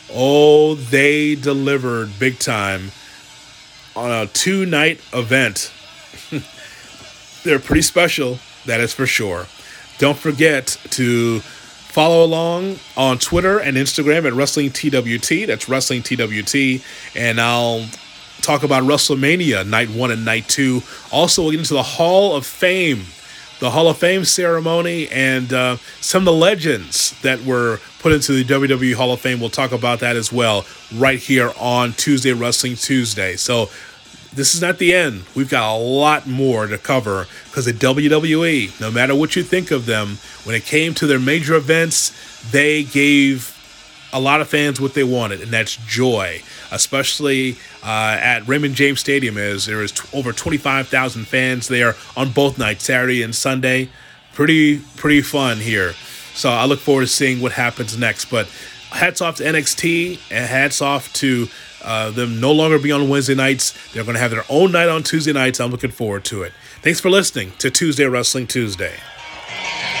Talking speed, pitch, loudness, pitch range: 165 wpm, 130 Hz, -16 LUFS, 120-150 Hz